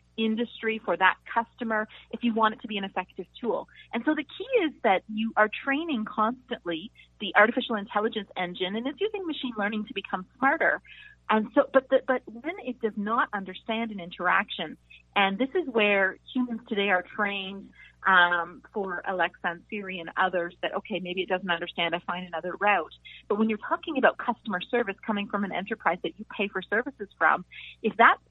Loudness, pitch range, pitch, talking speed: -27 LUFS, 185-240 Hz, 215 Hz, 195 wpm